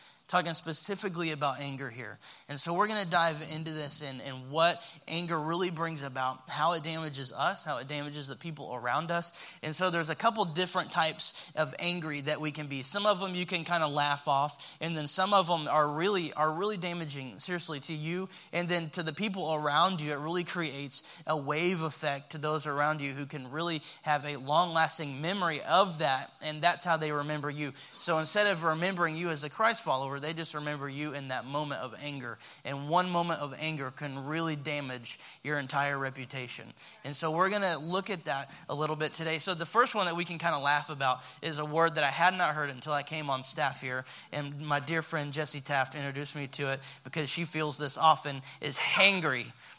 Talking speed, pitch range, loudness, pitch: 220 wpm, 140-170 Hz, -31 LUFS, 155 Hz